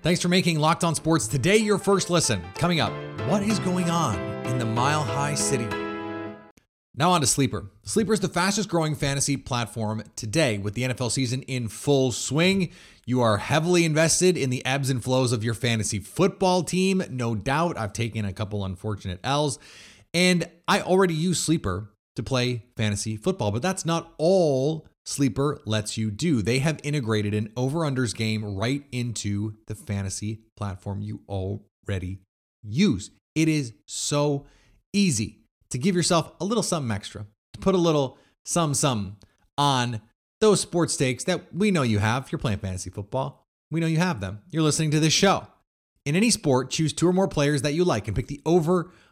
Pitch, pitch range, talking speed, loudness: 135 Hz, 110-165 Hz, 180 wpm, -24 LUFS